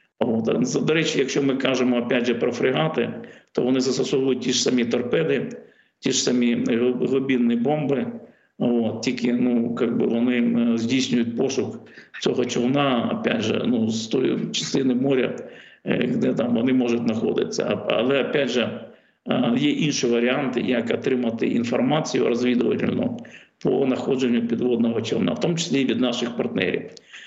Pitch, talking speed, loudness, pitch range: 125 Hz, 140 wpm, -22 LUFS, 120-130 Hz